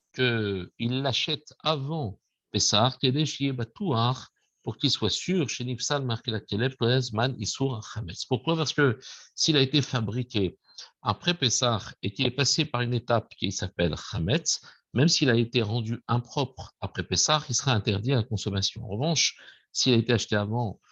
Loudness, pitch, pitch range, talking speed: -27 LUFS, 120 Hz, 110-135 Hz, 140 wpm